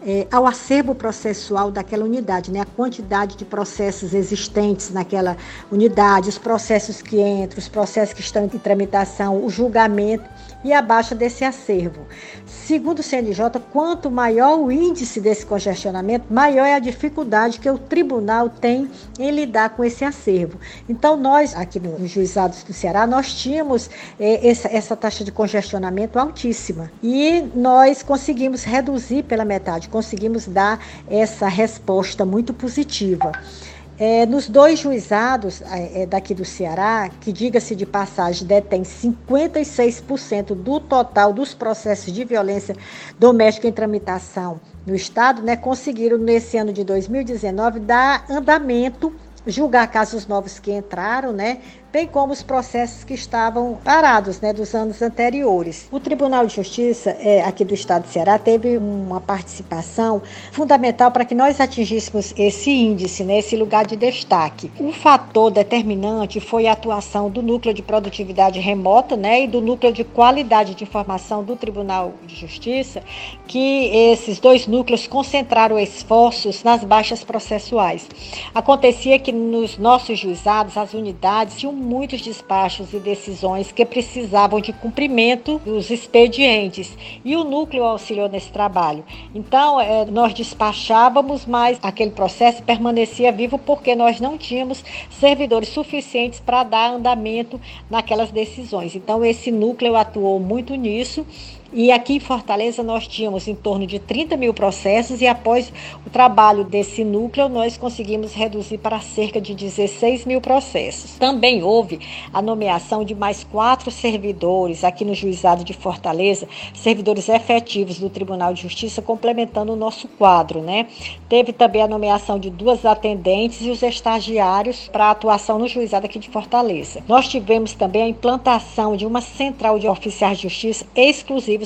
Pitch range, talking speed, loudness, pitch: 205-245 Hz, 145 wpm, -18 LUFS, 225 Hz